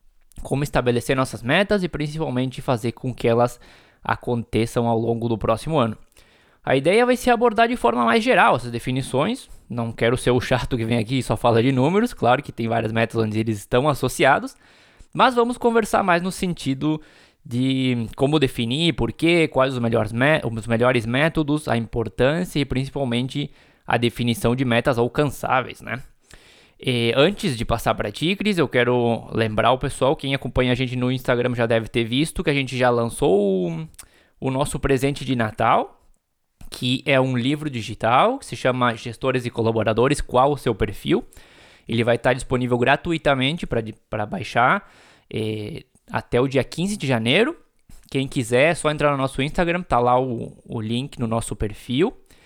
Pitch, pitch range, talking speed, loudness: 130 Hz, 115-150 Hz, 175 wpm, -21 LUFS